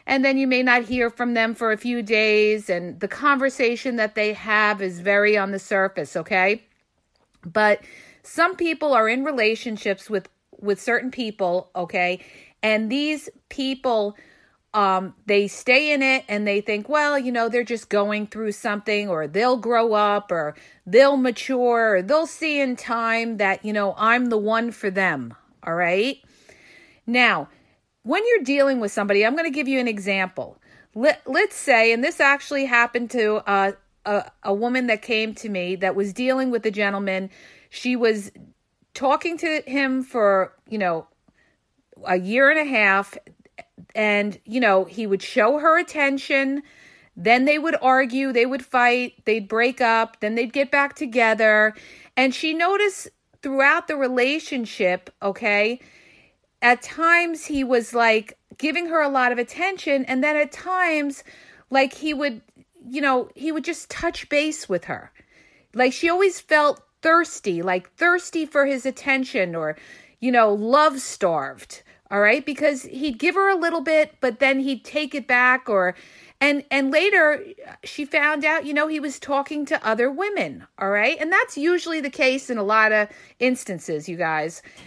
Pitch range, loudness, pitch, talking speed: 210-290 Hz, -21 LUFS, 245 Hz, 170 wpm